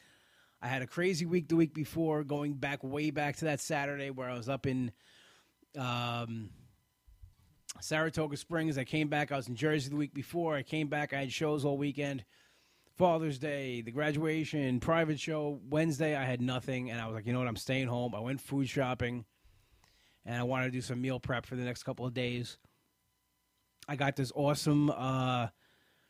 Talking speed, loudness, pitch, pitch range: 195 wpm, -34 LUFS, 140 Hz, 125-150 Hz